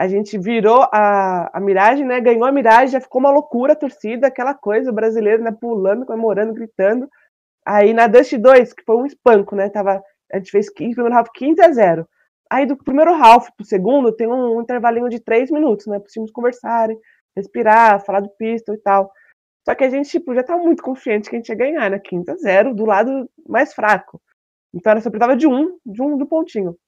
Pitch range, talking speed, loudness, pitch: 210-260 Hz, 225 wpm, -15 LUFS, 230 Hz